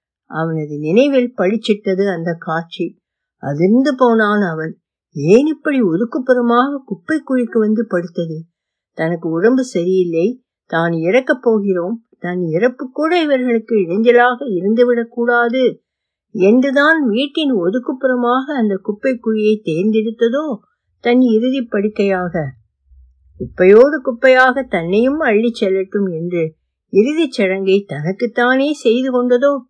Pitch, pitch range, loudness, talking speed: 220 Hz, 180-255 Hz, -15 LUFS, 100 wpm